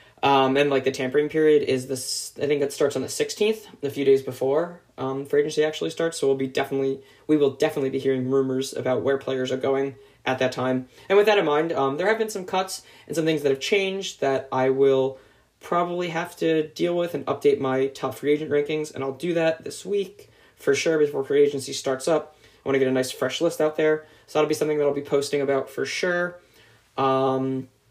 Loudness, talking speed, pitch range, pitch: -24 LUFS, 235 wpm, 135-165 Hz, 145 Hz